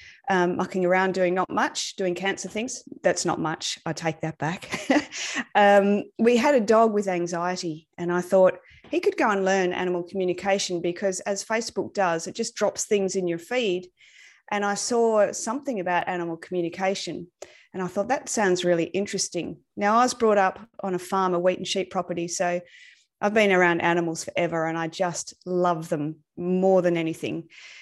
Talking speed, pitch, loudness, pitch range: 185 wpm, 185 Hz, -24 LUFS, 175-210 Hz